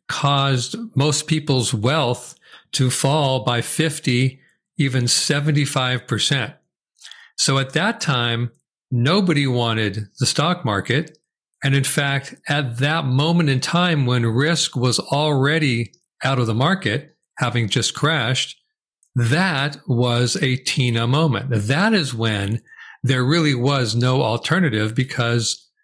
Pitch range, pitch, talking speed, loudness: 120-155 Hz, 135 Hz, 120 wpm, -19 LUFS